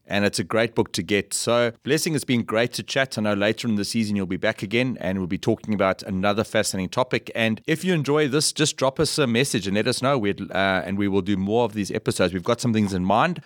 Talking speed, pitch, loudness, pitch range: 270 wpm, 110 Hz, -23 LUFS, 100-125 Hz